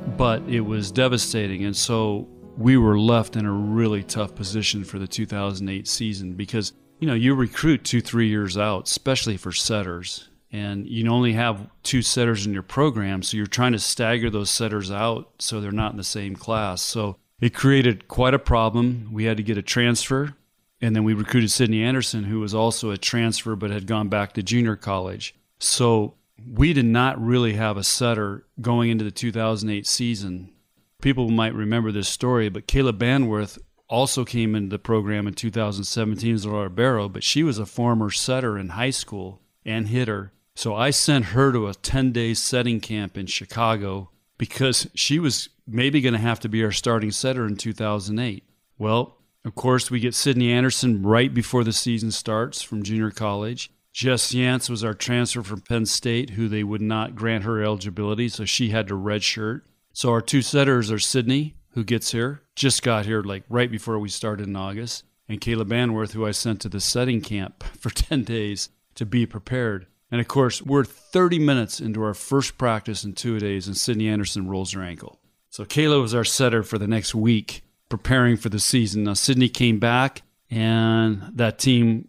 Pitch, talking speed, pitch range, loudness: 115 Hz, 190 wpm, 105-120 Hz, -22 LUFS